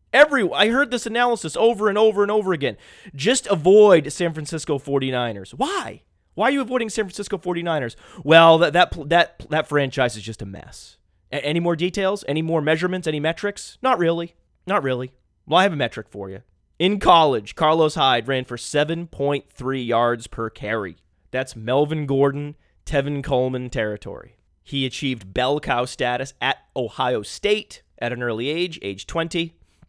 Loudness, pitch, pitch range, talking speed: -21 LUFS, 150 Hz, 125-180 Hz, 170 wpm